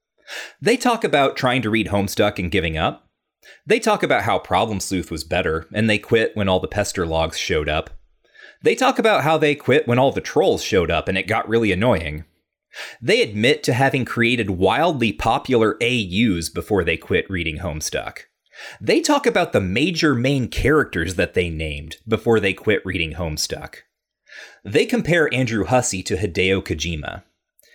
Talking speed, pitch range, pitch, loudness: 175 wpm, 85-125 Hz, 100 Hz, -19 LUFS